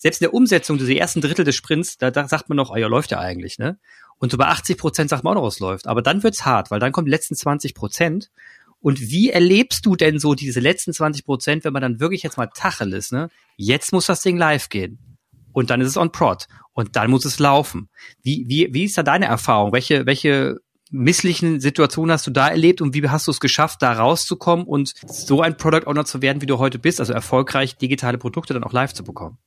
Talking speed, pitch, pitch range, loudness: 245 wpm, 145 Hz, 125-165 Hz, -19 LUFS